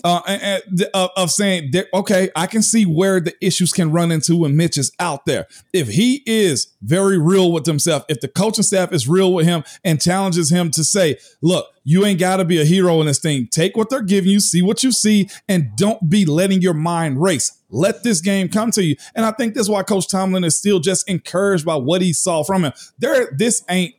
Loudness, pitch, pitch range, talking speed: -17 LUFS, 185 Hz, 165-195 Hz, 235 wpm